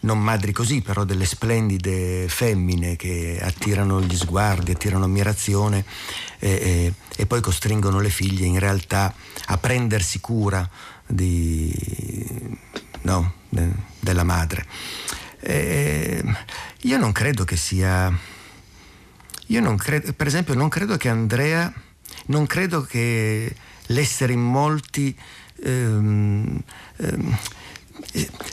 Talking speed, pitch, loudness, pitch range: 110 wpm, 100 Hz, -22 LUFS, 90-120 Hz